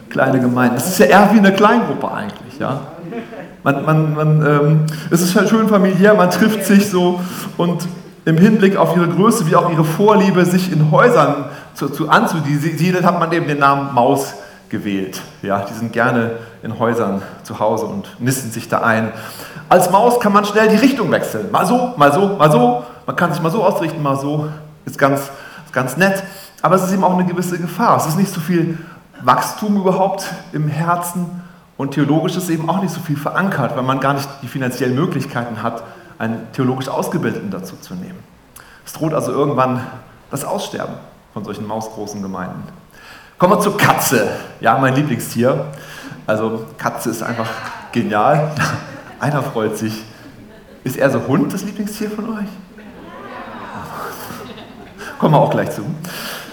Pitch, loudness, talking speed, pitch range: 155 Hz, -16 LUFS, 175 wpm, 125-190 Hz